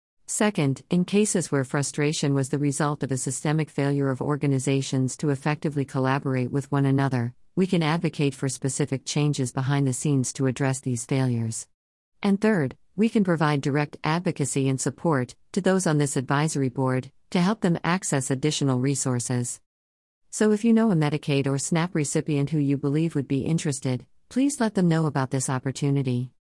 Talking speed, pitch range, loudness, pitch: 170 wpm, 135-155 Hz, -25 LUFS, 140 Hz